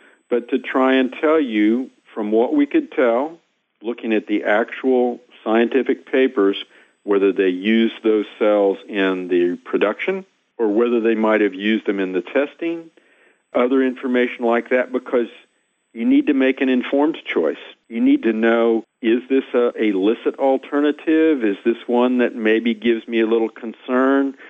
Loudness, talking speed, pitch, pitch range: -19 LUFS, 160 wpm, 120 Hz, 110-135 Hz